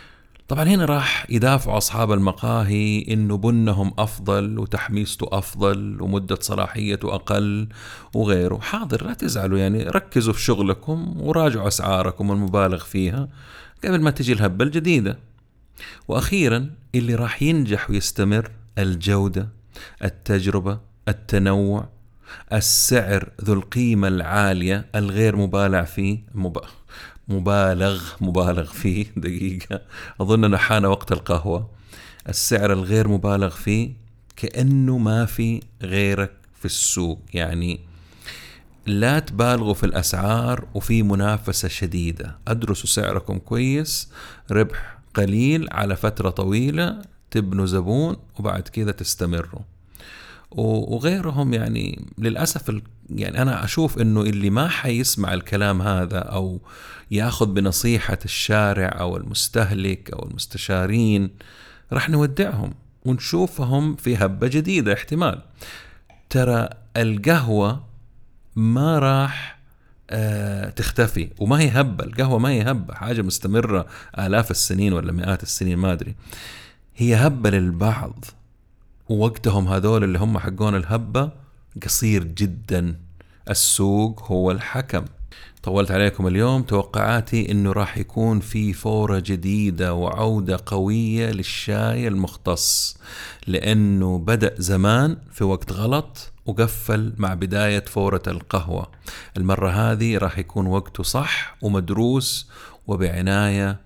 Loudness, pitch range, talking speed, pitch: -21 LUFS, 95-115 Hz, 105 wpm, 105 Hz